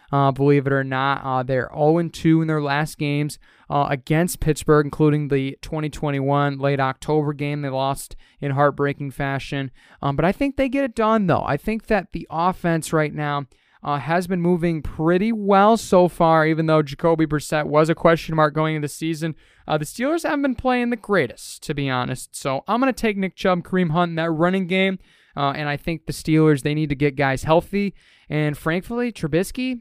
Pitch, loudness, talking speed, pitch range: 155 Hz, -21 LUFS, 205 wpm, 145-180 Hz